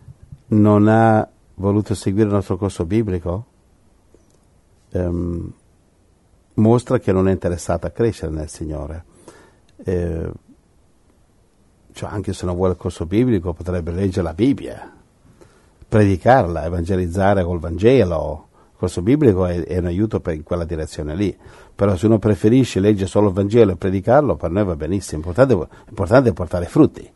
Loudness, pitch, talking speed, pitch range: -18 LUFS, 95 Hz, 145 wpm, 85-105 Hz